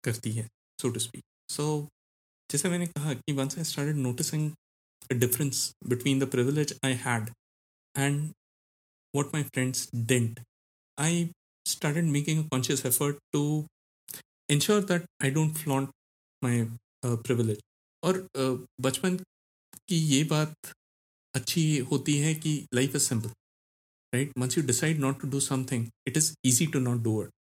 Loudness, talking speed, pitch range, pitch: -29 LUFS, 145 wpm, 120-150 Hz, 135 Hz